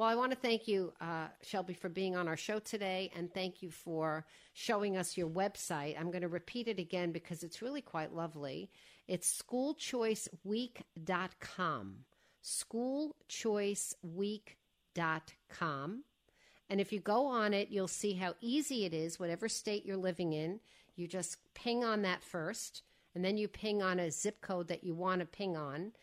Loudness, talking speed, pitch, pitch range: -39 LUFS, 170 wpm, 185 Hz, 170-215 Hz